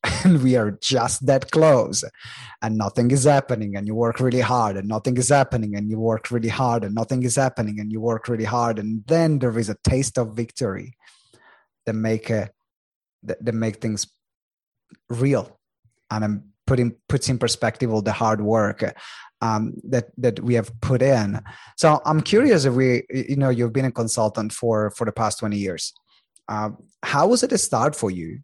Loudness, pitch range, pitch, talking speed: -21 LUFS, 110-130 Hz, 115 Hz, 190 wpm